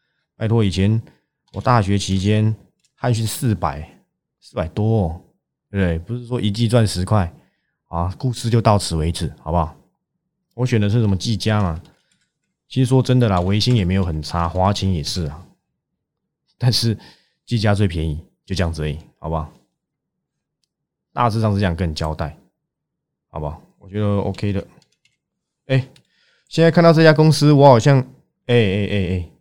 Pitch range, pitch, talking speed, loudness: 90-120 Hz, 105 Hz, 245 characters per minute, -19 LUFS